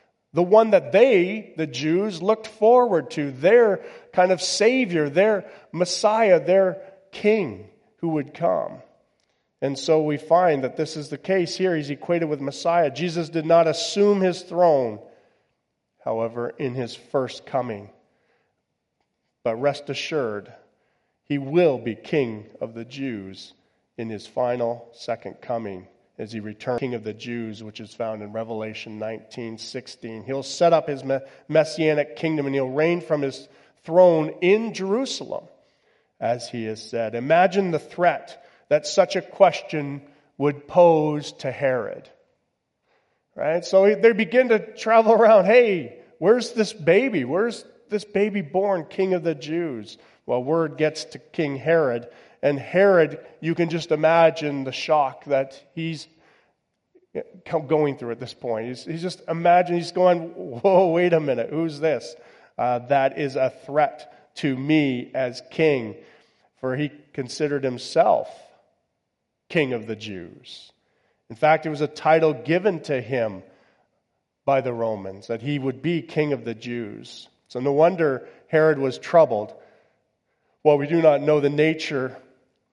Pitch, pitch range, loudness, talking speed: 155 Hz, 130-175 Hz, -22 LUFS, 150 wpm